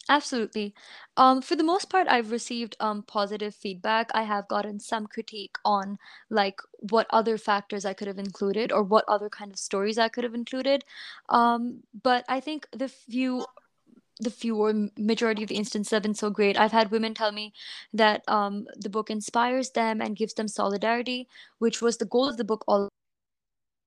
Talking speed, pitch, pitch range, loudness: 185 wpm, 220 Hz, 210-240 Hz, -27 LUFS